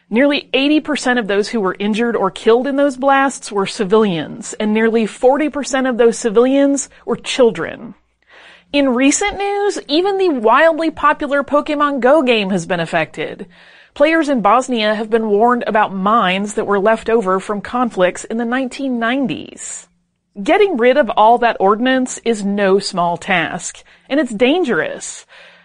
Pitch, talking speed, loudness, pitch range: 235 Hz, 150 wpm, -15 LUFS, 210-280 Hz